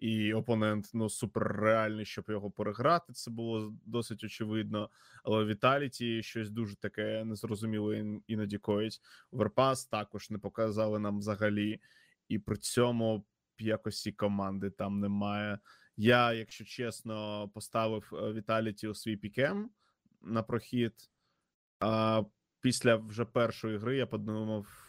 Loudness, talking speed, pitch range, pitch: -34 LUFS, 125 wpm, 105-115 Hz, 110 Hz